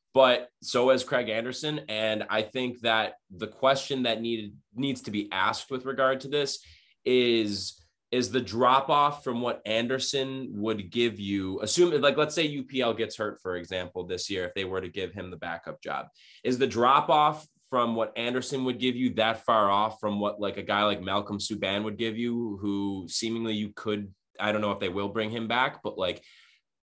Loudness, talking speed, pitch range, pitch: -28 LUFS, 205 wpm, 105-130 Hz, 115 Hz